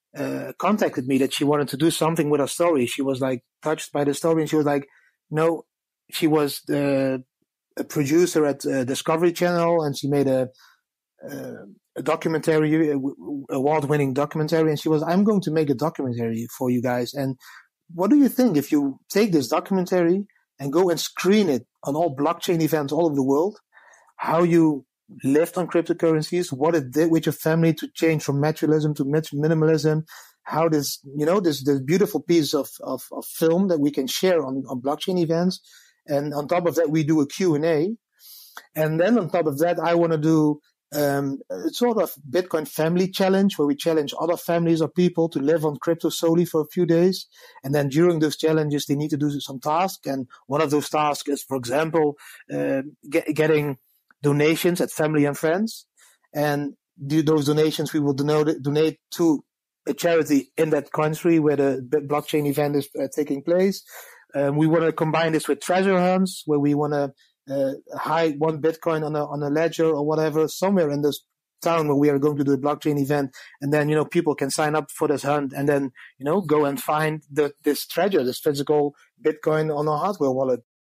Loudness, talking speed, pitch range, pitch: -22 LUFS, 205 wpm, 145-165 Hz, 155 Hz